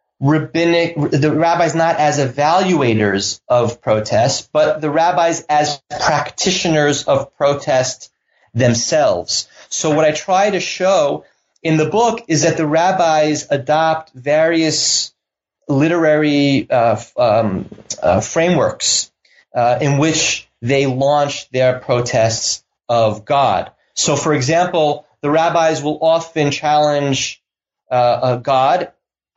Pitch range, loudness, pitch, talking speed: 135-160 Hz, -15 LUFS, 150 Hz, 115 wpm